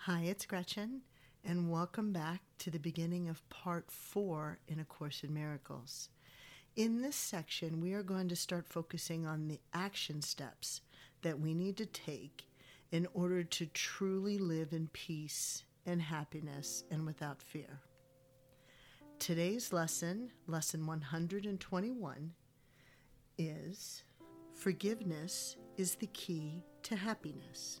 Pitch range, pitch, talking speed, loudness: 140-180 Hz, 165 Hz, 125 wpm, -41 LUFS